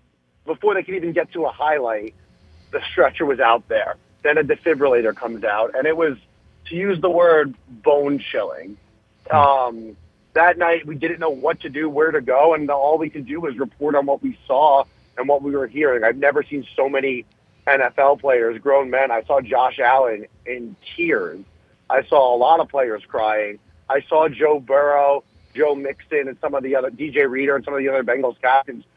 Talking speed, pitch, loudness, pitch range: 200 wpm, 140 Hz, -19 LUFS, 120-160 Hz